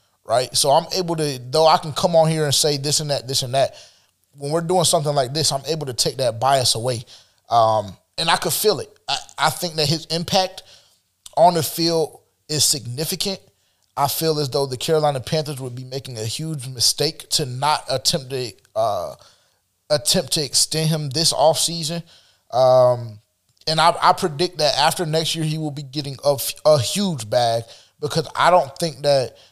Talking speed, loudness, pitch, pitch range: 195 wpm, -19 LUFS, 150 Hz, 130-160 Hz